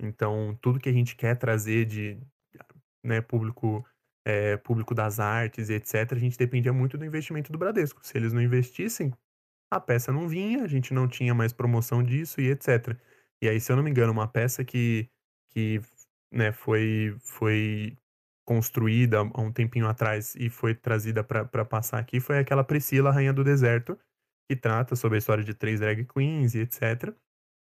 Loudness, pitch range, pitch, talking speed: -27 LUFS, 110-130 Hz, 120 Hz, 180 wpm